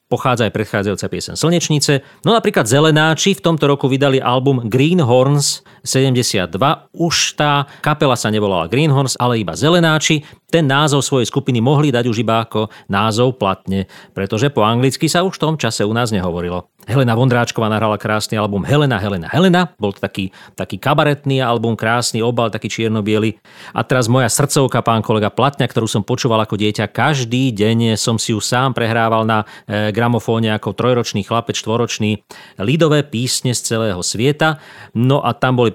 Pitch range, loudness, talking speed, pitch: 110-140 Hz, -16 LUFS, 170 wpm, 120 Hz